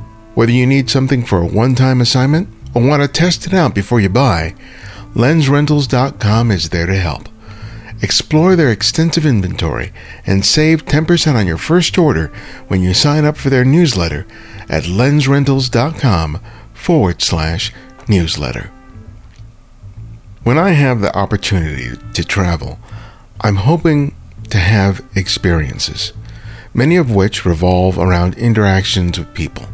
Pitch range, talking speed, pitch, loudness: 95-130 Hz, 135 wpm, 110 Hz, -13 LUFS